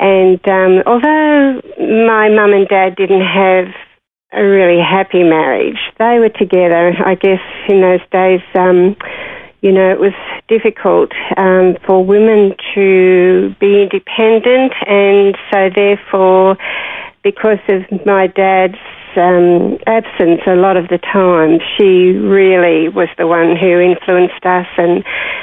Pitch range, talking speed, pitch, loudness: 180-200 Hz, 130 wpm, 190 Hz, -10 LUFS